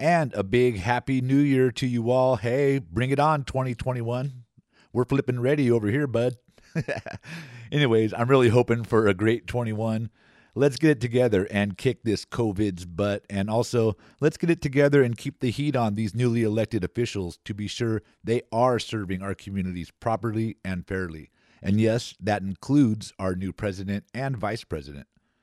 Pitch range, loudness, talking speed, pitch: 105-130 Hz, -25 LUFS, 170 wpm, 115 Hz